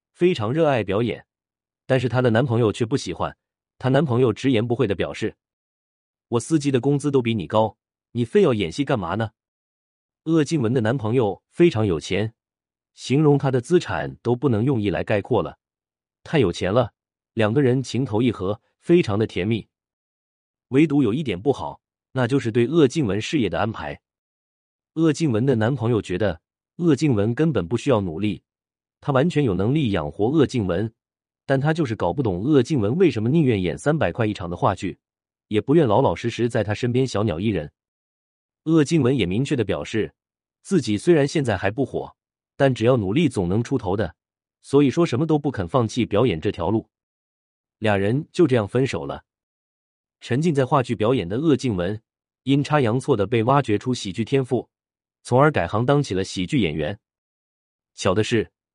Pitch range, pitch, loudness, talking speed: 100-140 Hz, 115 Hz, -22 LUFS, 270 characters per minute